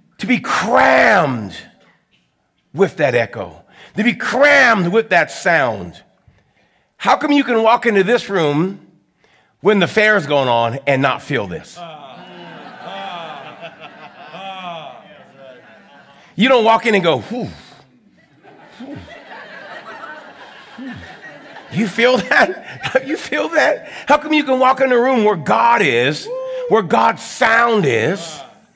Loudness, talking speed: -15 LUFS, 125 wpm